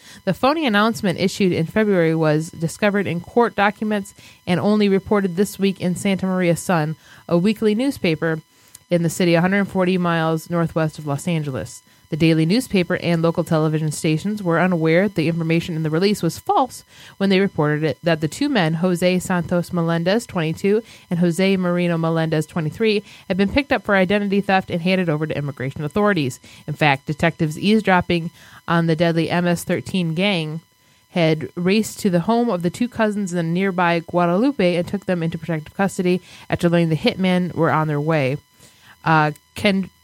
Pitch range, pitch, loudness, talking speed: 160-195 Hz, 175 Hz, -20 LUFS, 175 wpm